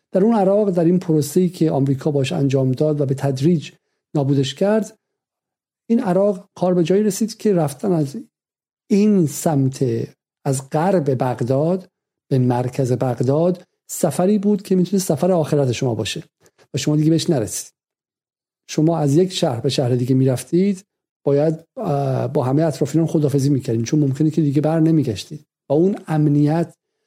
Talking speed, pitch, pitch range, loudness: 155 wpm, 155 Hz, 140-180 Hz, -19 LUFS